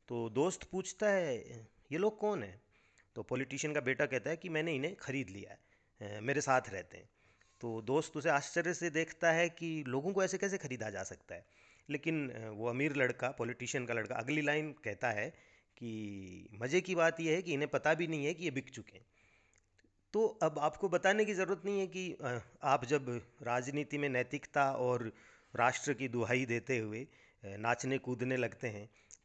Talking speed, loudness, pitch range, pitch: 190 wpm, -36 LUFS, 115-160 Hz, 135 Hz